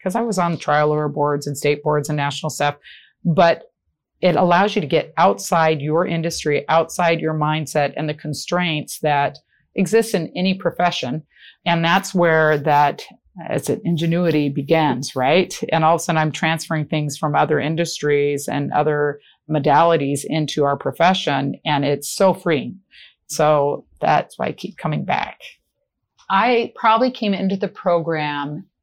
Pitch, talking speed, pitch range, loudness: 155 Hz, 160 wpm, 145-175 Hz, -19 LUFS